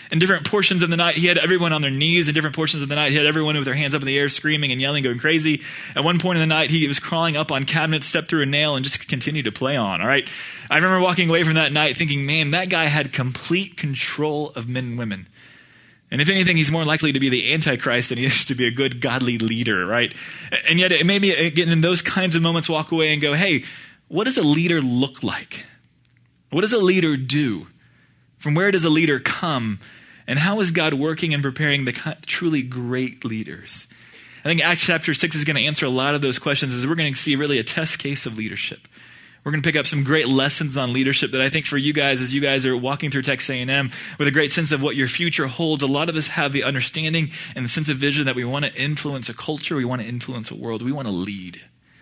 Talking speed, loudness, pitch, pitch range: 265 wpm, -20 LUFS, 150 Hz, 130-160 Hz